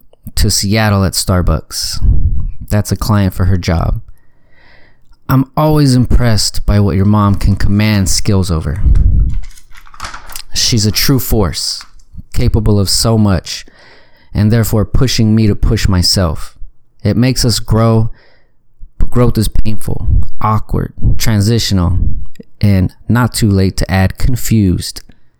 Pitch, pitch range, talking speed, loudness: 105 Hz, 95-115 Hz, 125 wpm, -13 LUFS